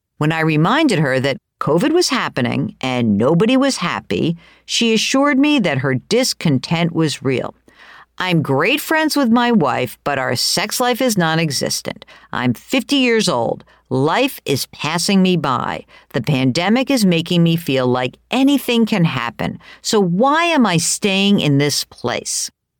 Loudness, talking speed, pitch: -16 LUFS, 155 wpm, 175 Hz